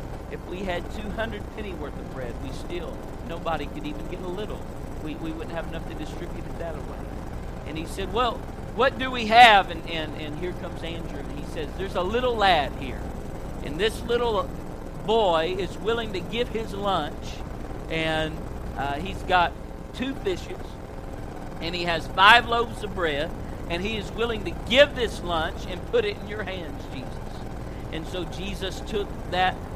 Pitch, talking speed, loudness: 185 Hz, 185 wpm, -26 LUFS